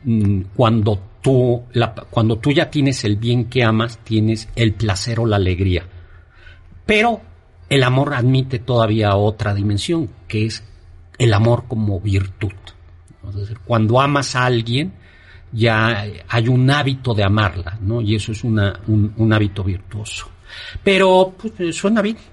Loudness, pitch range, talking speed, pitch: -18 LUFS, 100-125 Hz, 145 wpm, 110 Hz